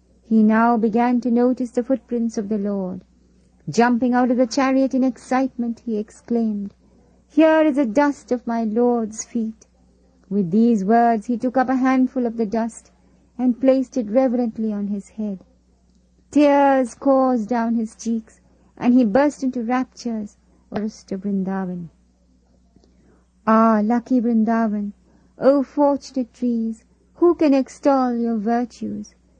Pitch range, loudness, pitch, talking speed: 215-255 Hz, -20 LUFS, 235 Hz, 140 wpm